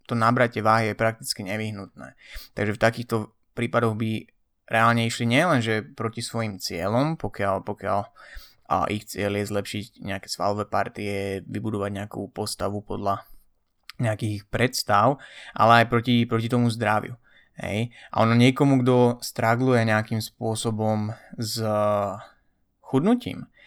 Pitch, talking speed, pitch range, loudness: 110 Hz, 125 wpm, 105-120 Hz, -24 LUFS